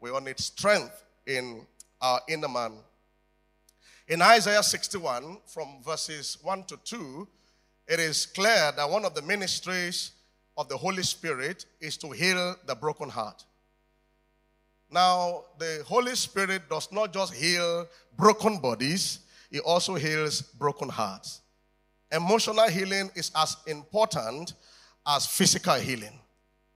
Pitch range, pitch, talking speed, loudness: 150-195 Hz, 165 Hz, 130 wpm, -27 LUFS